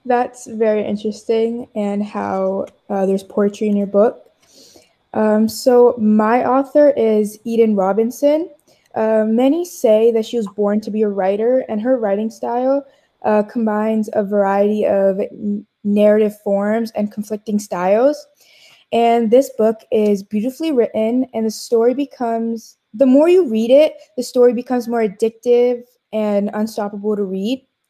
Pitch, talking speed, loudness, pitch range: 220 Hz, 145 wpm, -17 LUFS, 210-245 Hz